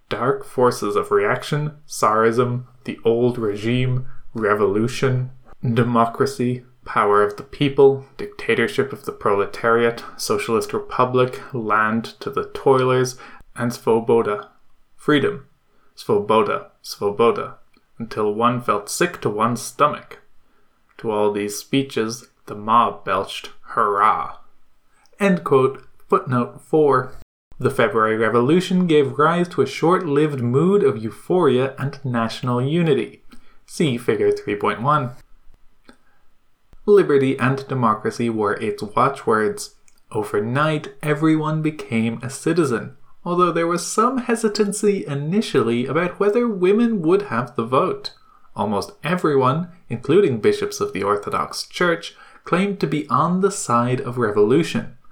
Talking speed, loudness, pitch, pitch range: 115 wpm, -20 LUFS, 135 Hz, 120-185 Hz